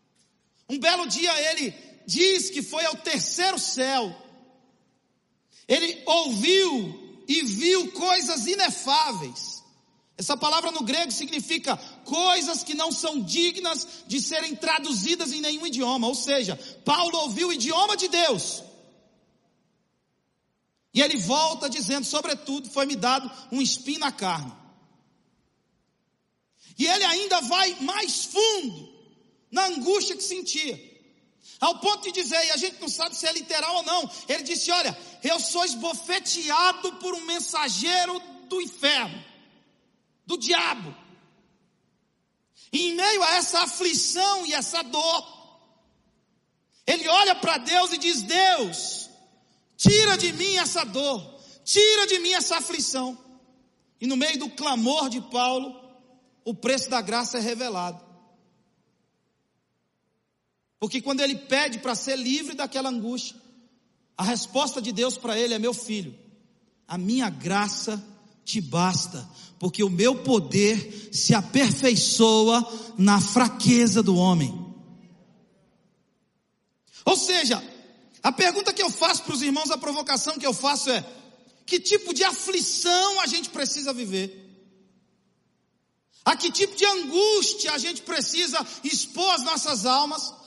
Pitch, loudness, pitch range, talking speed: 280 Hz, -23 LUFS, 240-340 Hz, 130 wpm